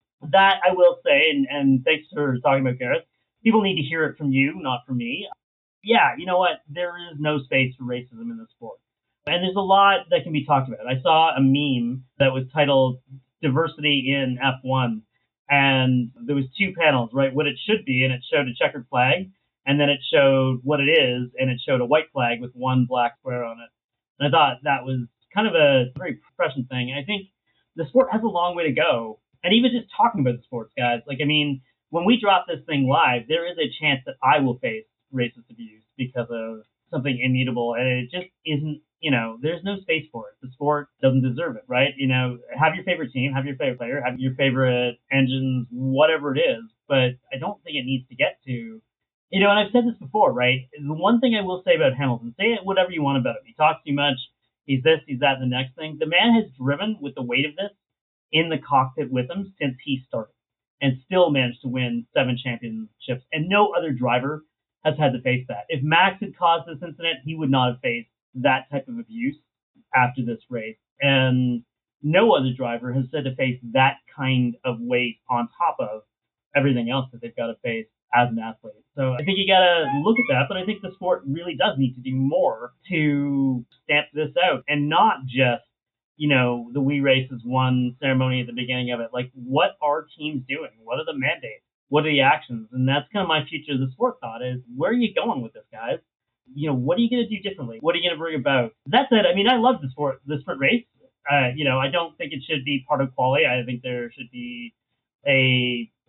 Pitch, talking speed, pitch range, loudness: 135 Hz, 230 wpm, 125-165 Hz, -22 LUFS